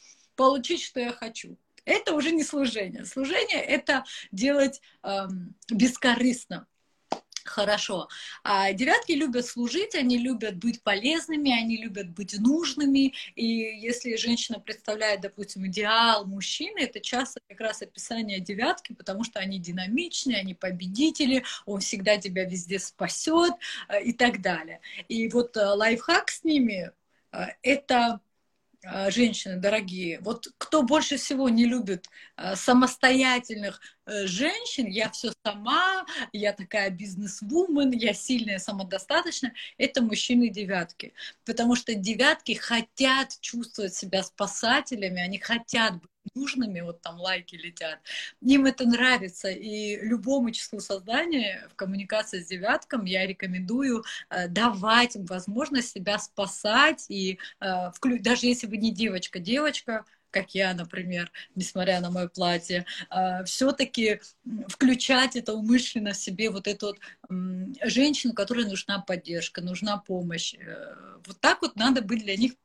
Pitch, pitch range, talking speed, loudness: 225 Hz, 195-255 Hz, 125 wpm, -26 LUFS